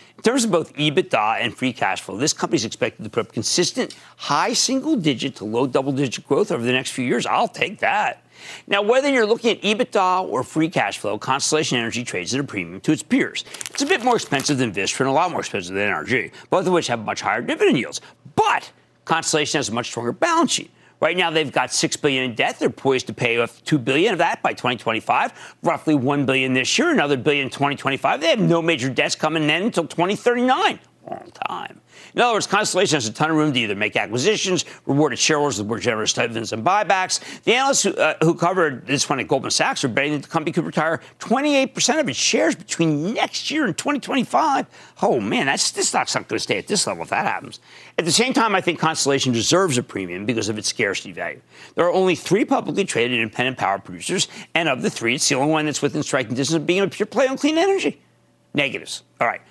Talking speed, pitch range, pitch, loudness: 235 wpm, 130-200 Hz, 155 Hz, -20 LUFS